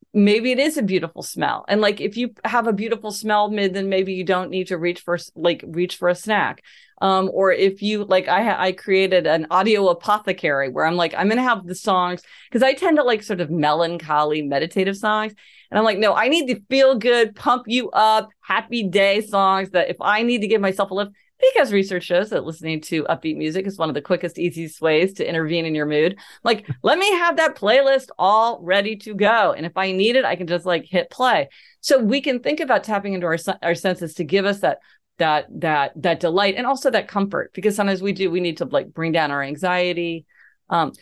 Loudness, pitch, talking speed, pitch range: -20 LUFS, 195 Hz, 230 wpm, 175-220 Hz